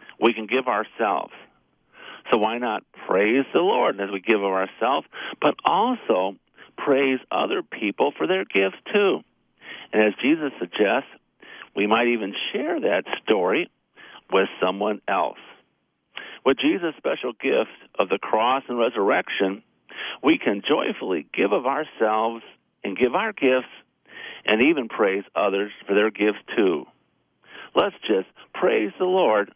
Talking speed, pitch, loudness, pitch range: 140 wpm, 110 Hz, -23 LUFS, 100-125 Hz